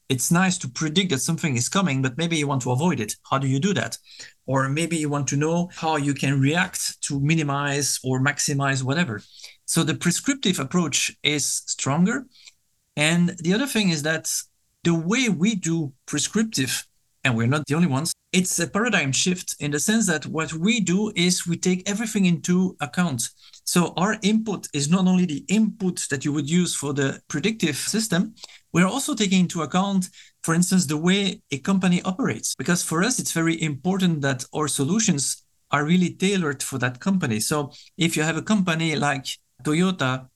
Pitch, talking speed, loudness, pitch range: 165 Hz, 185 wpm, -23 LUFS, 140-185 Hz